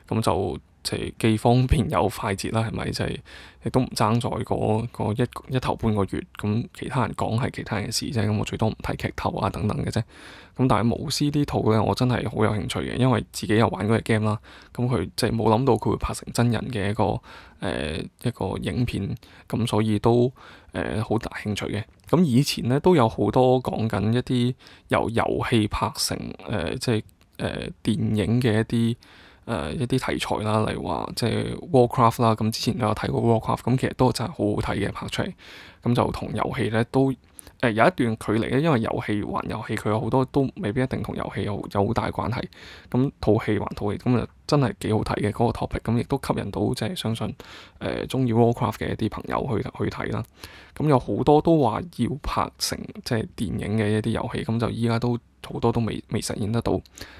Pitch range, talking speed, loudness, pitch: 105-125 Hz, 340 characters per minute, -24 LUFS, 110 Hz